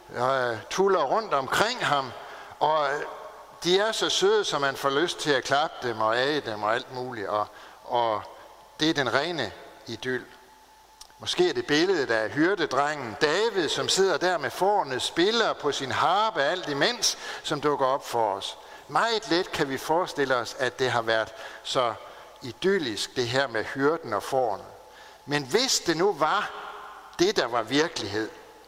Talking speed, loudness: 170 wpm, -26 LUFS